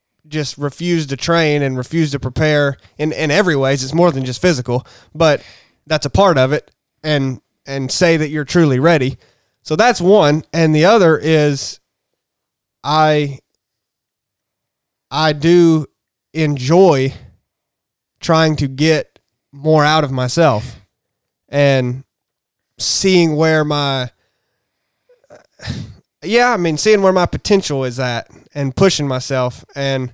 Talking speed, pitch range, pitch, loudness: 130 wpm, 130-165 Hz, 150 Hz, -15 LUFS